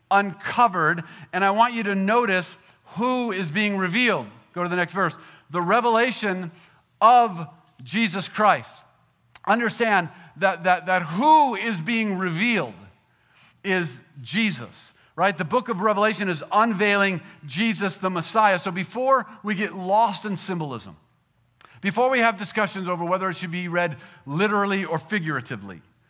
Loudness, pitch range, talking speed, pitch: -22 LUFS, 170-215 Hz, 140 wpm, 190 Hz